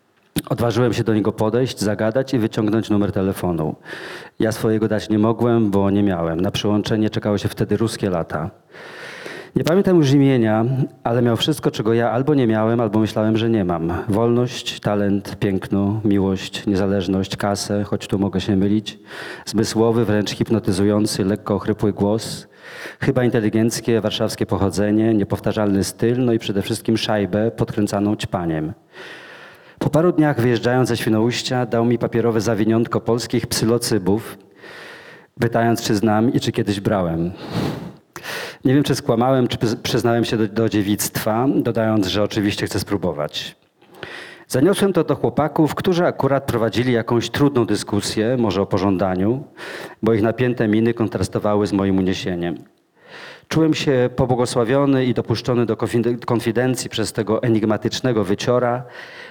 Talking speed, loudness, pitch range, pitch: 140 wpm, -19 LUFS, 105-125 Hz, 115 Hz